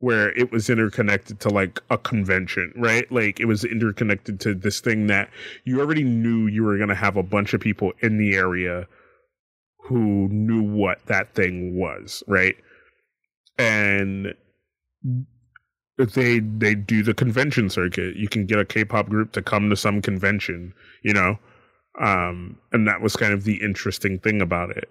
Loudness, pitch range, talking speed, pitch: -22 LUFS, 100-115 Hz, 170 wpm, 105 Hz